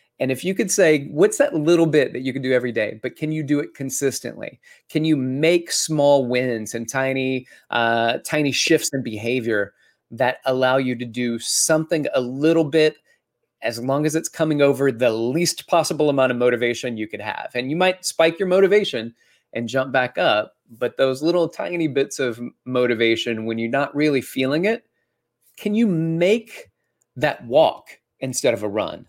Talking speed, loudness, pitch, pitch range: 185 wpm, -20 LUFS, 135 Hz, 125-160 Hz